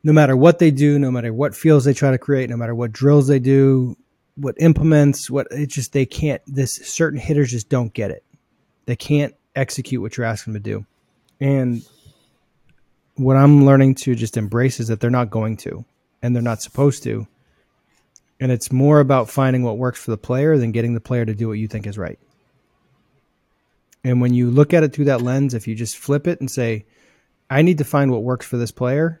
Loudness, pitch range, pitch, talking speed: -18 LUFS, 115-145 Hz, 130 Hz, 220 wpm